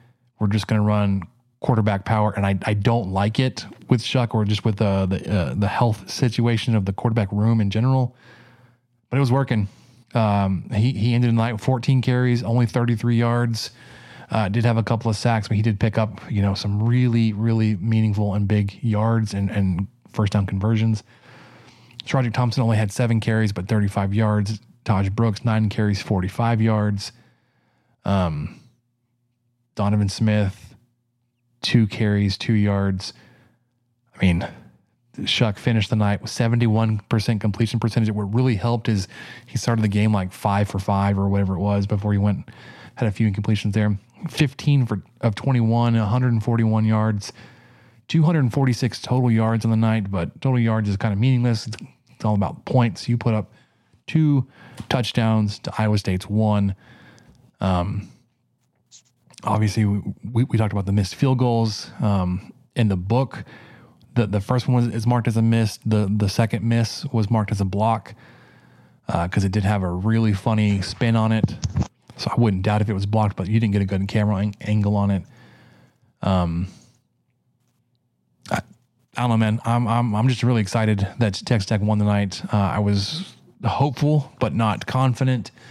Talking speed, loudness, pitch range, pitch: 175 wpm, -21 LUFS, 105-120 Hz, 110 Hz